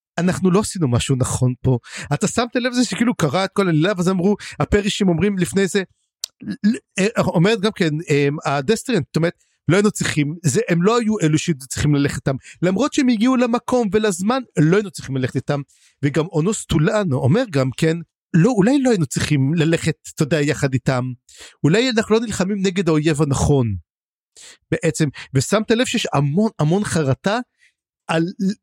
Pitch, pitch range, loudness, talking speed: 170 Hz, 150-210 Hz, -19 LUFS, 170 wpm